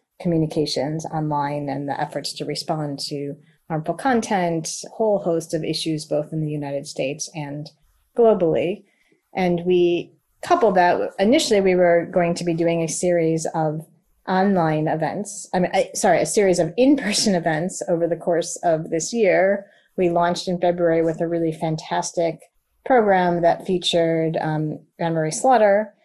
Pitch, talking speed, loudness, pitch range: 170 Hz, 155 wpm, -21 LUFS, 155-185 Hz